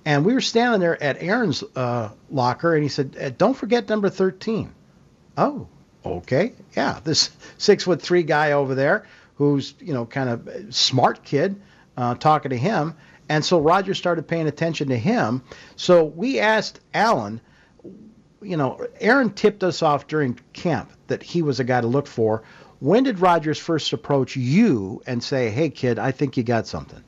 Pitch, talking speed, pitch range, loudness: 150 Hz, 175 wpm, 130-185 Hz, -21 LUFS